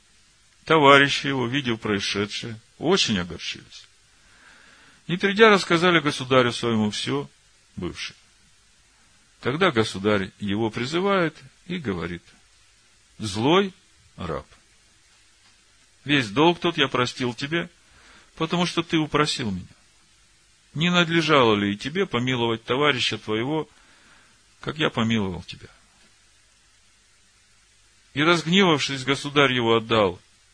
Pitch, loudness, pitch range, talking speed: 115 Hz, -22 LUFS, 105-150 Hz, 95 wpm